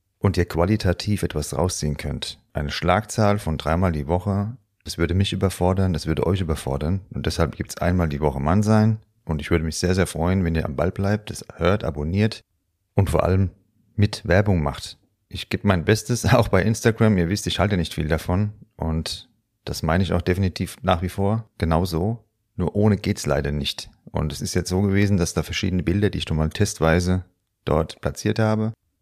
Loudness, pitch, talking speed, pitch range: -23 LUFS, 95 Hz, 200 wpm, 85-105 Hz